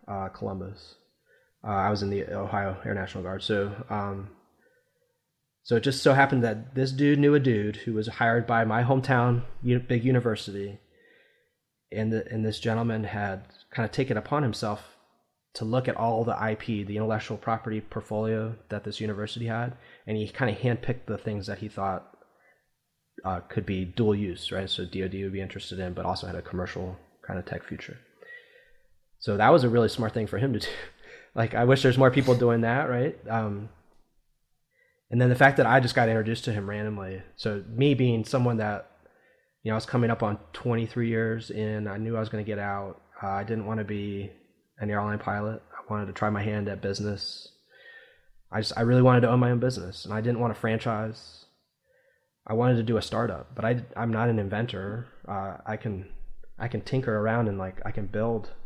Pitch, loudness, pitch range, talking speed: 110 Hz, -27 LUFS, 100-120 Hz, 205 wpm